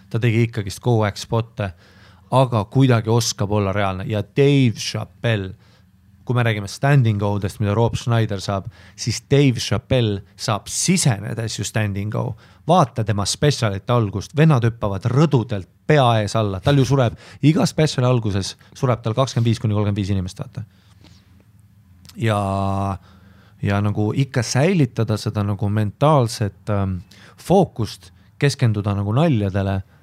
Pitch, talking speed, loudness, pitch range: 110 Hz, 140 wpm, -20 LUFS, 100-125 Hz